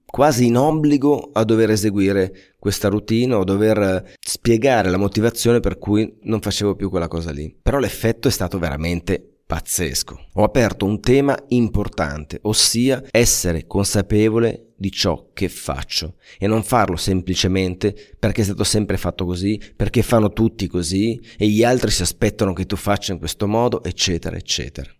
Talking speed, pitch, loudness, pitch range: 160 wpm, 105 Hz, -19 LUFS, 95-115 Hz